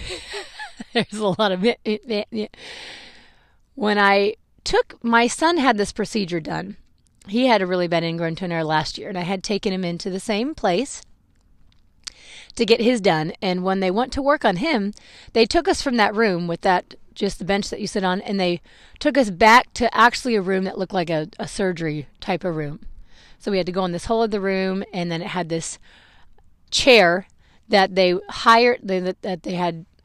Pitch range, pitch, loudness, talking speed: 180-230 Hz, 200 Hz, -20 LUFS, 205 wpm